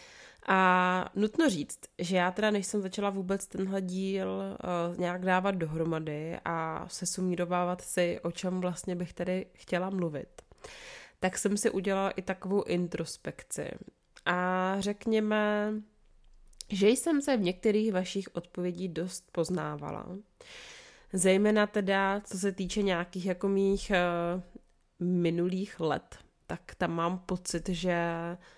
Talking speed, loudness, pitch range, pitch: 125 wpm, -31 LUFS, 175-200 Hz, 185 Hz